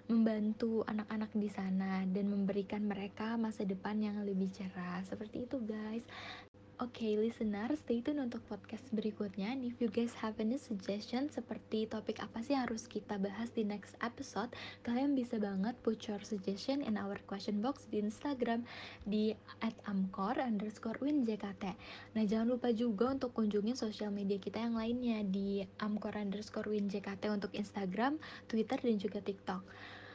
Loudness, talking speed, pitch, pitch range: -38 LUFS, 155 wpm, 215 Hz, 205-235 Hz